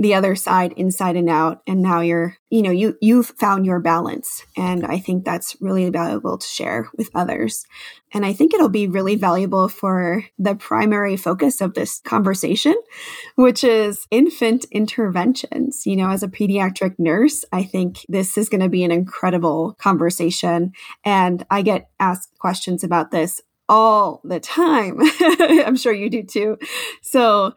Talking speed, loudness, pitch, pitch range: 165 wpm, -18 LUFS, 195 Hz, 180-220 Hz